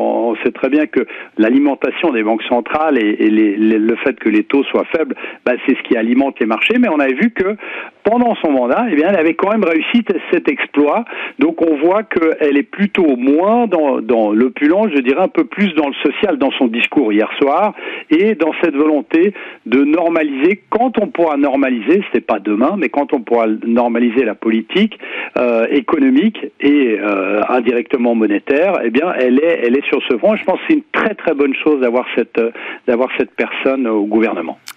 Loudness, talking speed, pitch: -14 LUFS, 205 wpm, 155 Hz